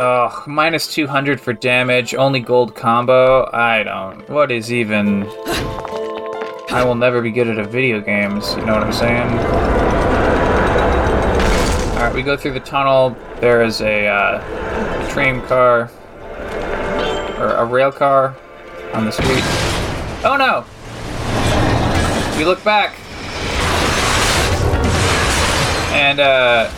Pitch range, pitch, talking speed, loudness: 95-125 Hz, 115 Hz, 125 wpm, -16 LUFS